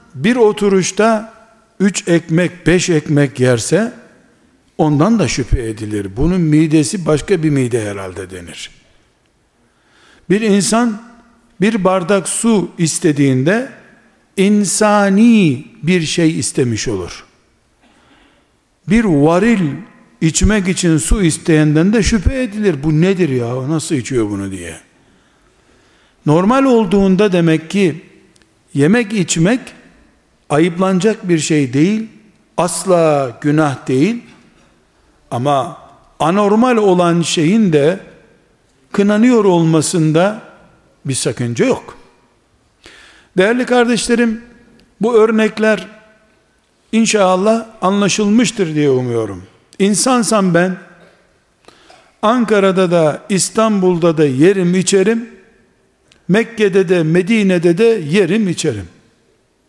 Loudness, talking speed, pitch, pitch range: -14 LUFS, 90 wpm, 185 Hz, 155-215 Hz